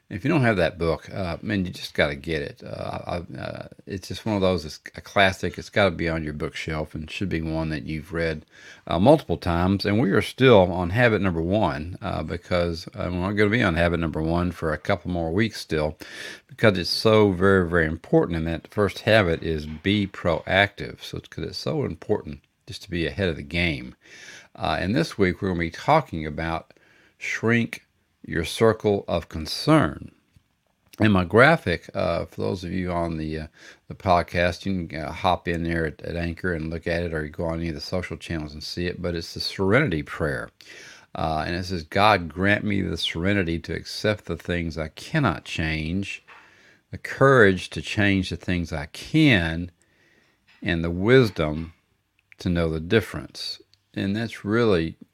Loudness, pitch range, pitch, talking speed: -24 LUFS, 80-100 Hz, 90 Hz, 200 wpm